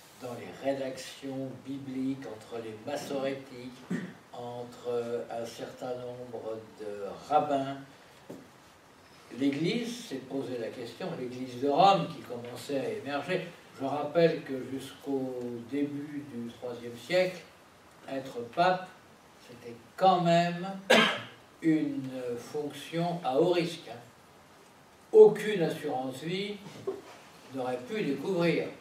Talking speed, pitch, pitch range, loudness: 100 wpm, 135 Hz, 125-170 Hz, -31 LUFS